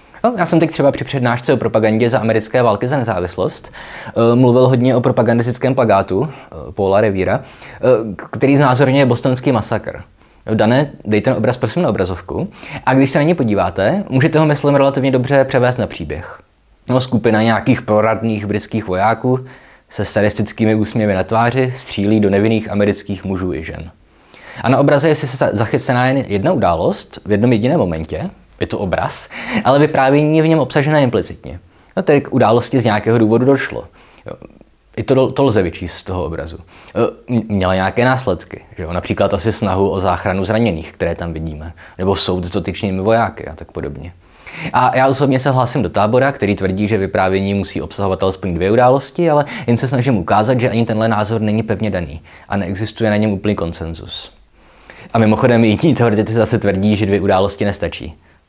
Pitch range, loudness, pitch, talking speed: 100-130 Hz, -15 LUFS, 110 Hz, 180 wpm